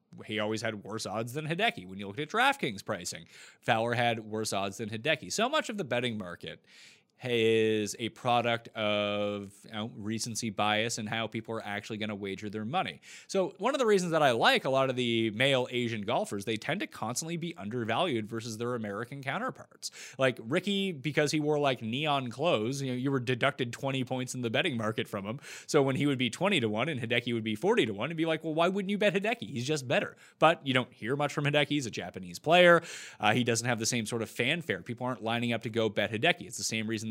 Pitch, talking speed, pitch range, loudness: 120 Hz, 240 wpm, 110-145 Hz, -30 LUFS